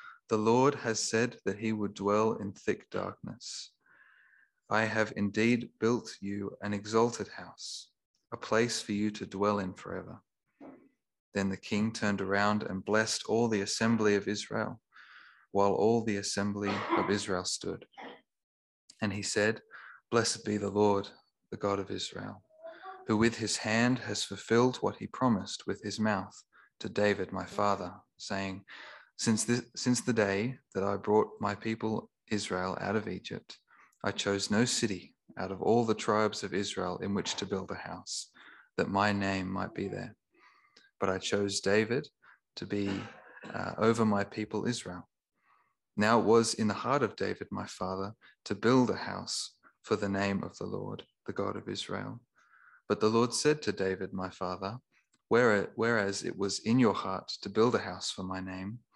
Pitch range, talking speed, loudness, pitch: 100-115 Hz, 170 wpm, -32 LUFS, 105 Hz